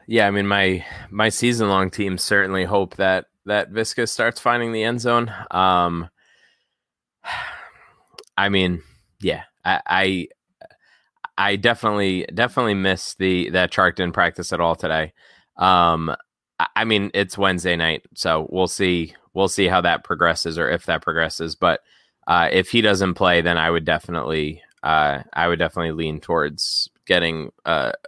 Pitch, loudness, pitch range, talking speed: 95 Hz, -20 LUFS, 85-100 Hz, 155 wpm